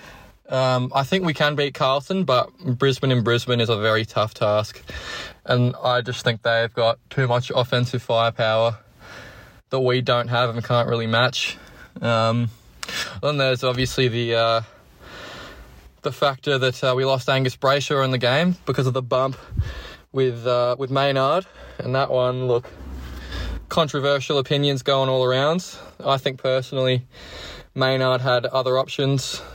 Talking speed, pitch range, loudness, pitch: 150 wpm, 115-135 Hz, -21 LUFS, 130 Hz